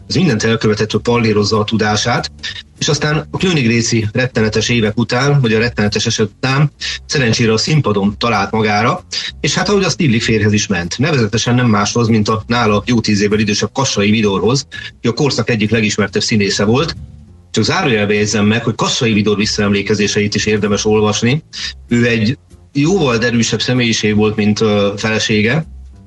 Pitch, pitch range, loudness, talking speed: 110 Hz, 105-120 Hz, -14 LUFS, 165 wpm